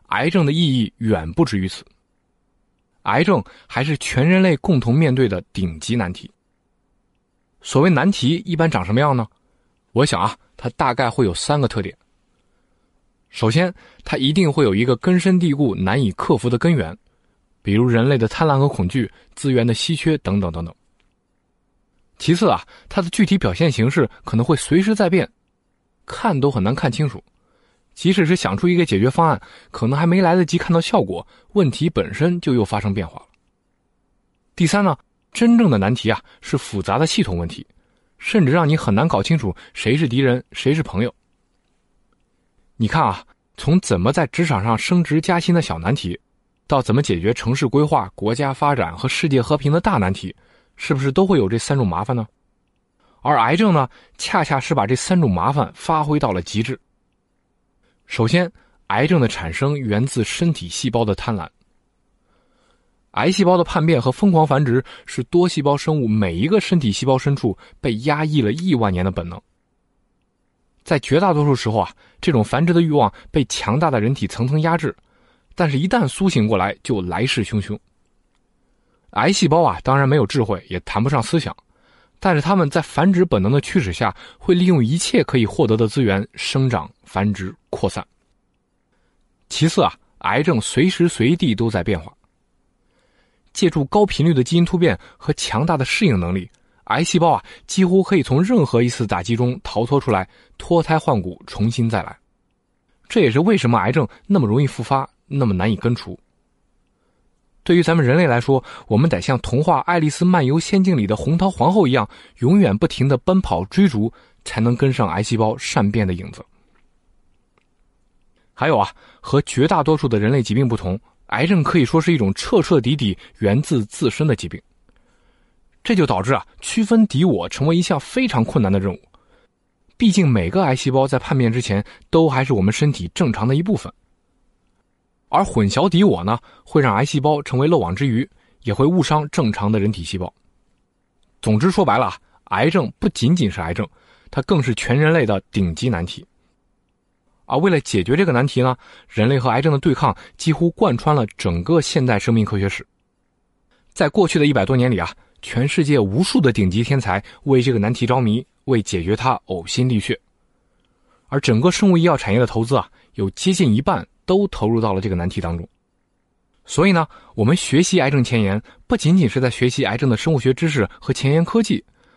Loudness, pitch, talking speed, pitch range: -18 LUFS, 135 Hz, 270 characters per minute, 110-165 Hz